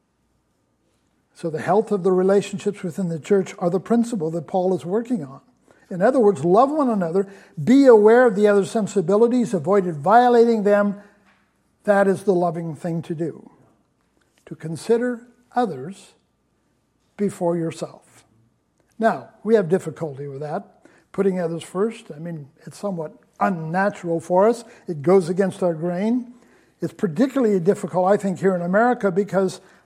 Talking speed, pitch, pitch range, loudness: 150 wpm, 195 Hz, 175-220 Hz, -20 LUFS